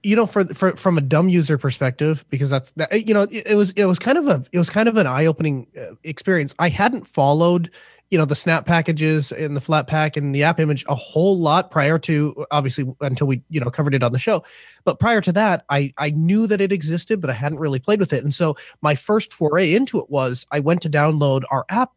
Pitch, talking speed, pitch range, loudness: 155 Hz, 250 wpm, 145-190 Hz, -19 LUFS